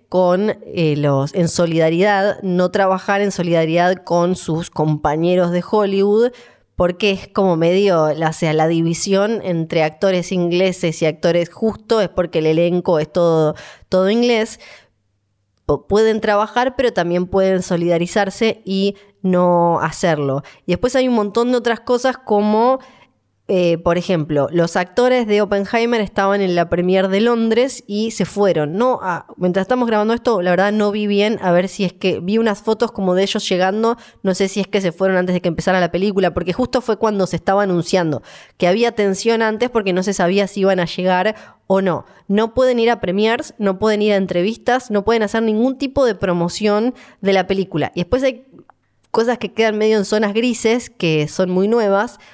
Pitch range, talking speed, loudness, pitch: 175-220 Hz, 185 wpm, -17 LUFS, 195 Hz